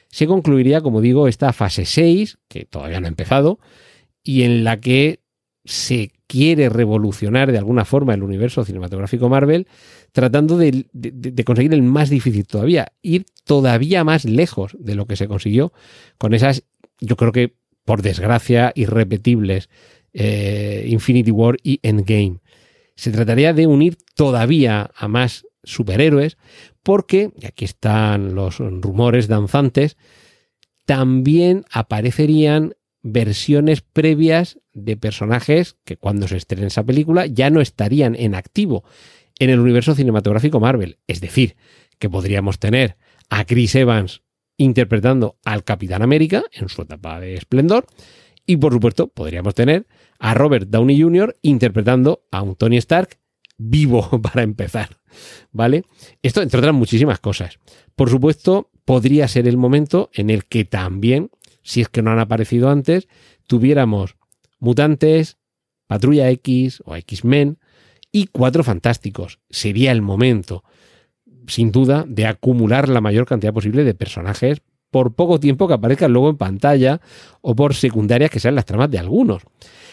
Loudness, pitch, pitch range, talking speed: -16 LUFS, 125 Hz, 110-145 Hz, 145 wpm